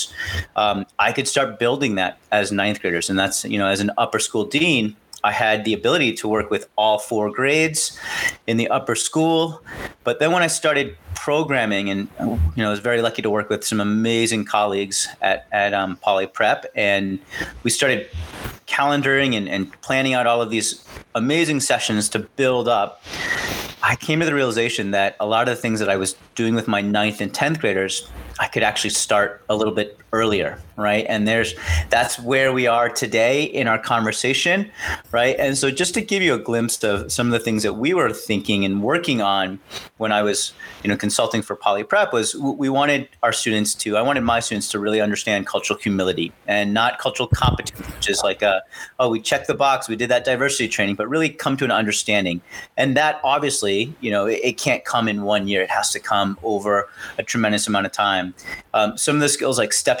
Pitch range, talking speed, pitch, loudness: 100-130 Hz, 210 wpm, 110 Hz, -20 LUFS